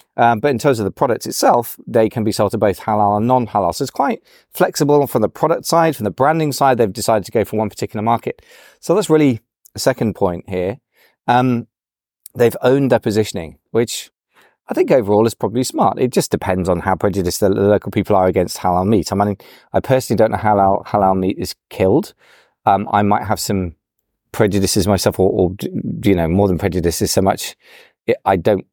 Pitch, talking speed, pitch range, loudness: 105 Hz, 210 wpm, 100-120 Hz, -17 LUFS